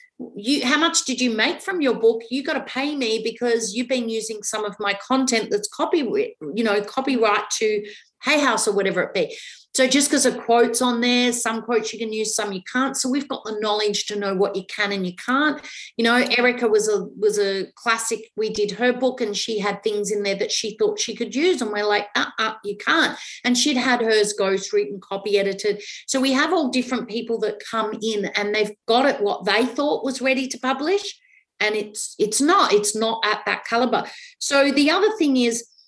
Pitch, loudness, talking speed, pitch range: 230 Hz, -21 LUFS, 225 wpm, 210-265 Hz